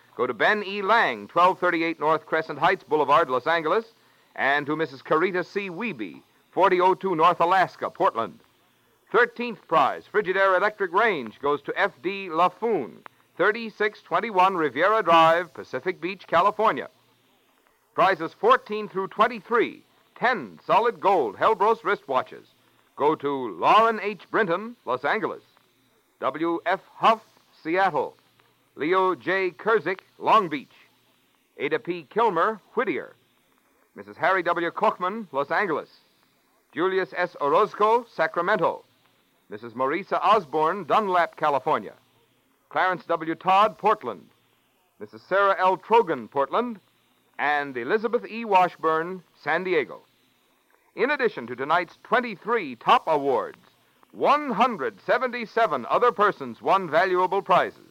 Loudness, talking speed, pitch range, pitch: -24 LUFS, 110 wpm, 165-215 Hz, 185 Hz